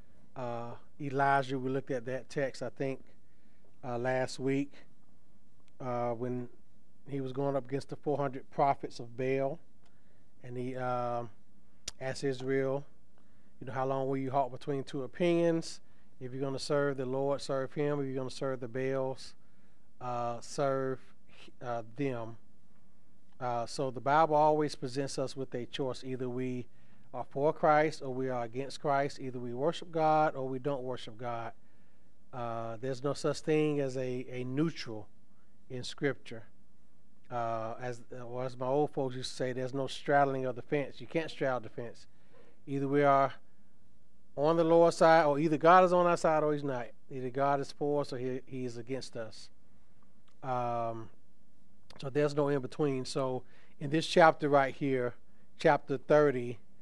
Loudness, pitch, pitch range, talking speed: -32 LUFS, 130 Hz, 120-140 Hz, 170 wpm